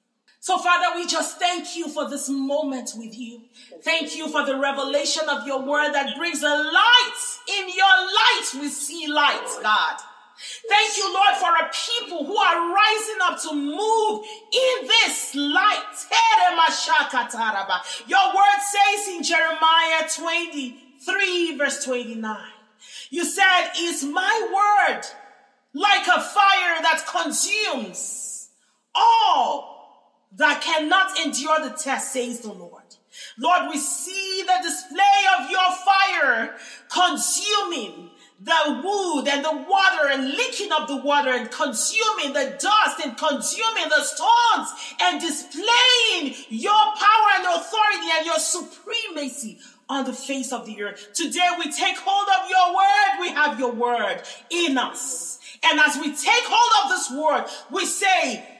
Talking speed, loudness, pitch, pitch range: 140 wpm, -20 LUFS, 335 Hz, 285-390 Hz